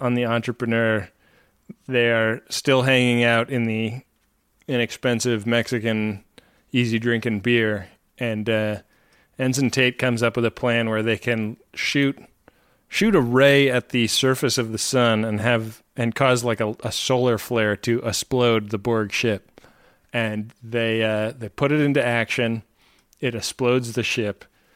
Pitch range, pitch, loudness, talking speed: 110-125 Hz, 120 Hz, -21 LUFS, 155 wpm